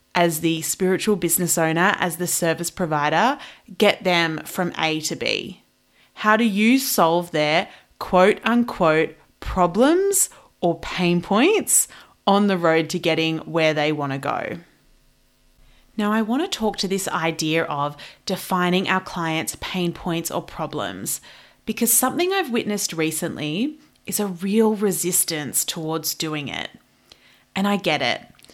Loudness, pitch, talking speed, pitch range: -21 LUFS, 180 Hz, 145 wpm, 160-210 Hz